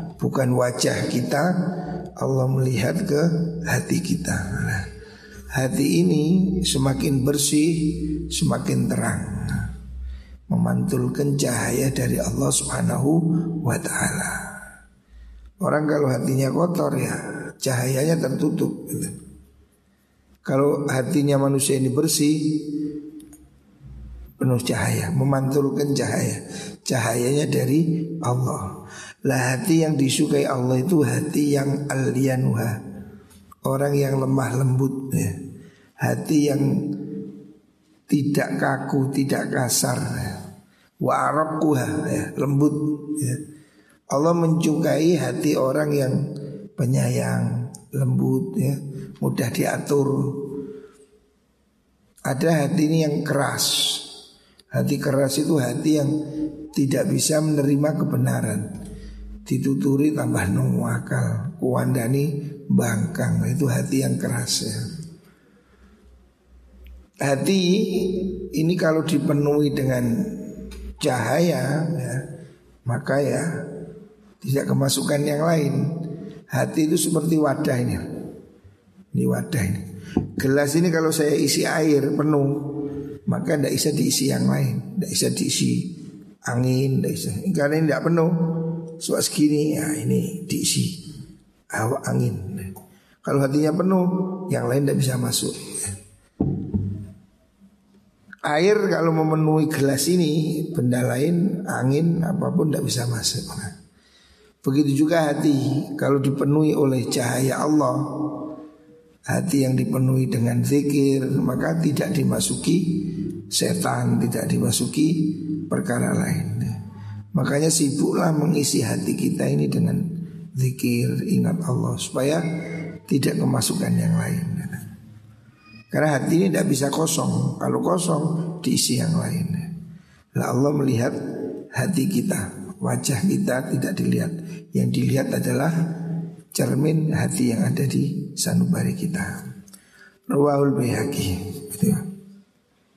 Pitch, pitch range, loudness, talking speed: 145 Hz, 125-160 Hz, -22 LUFS, 100 wpm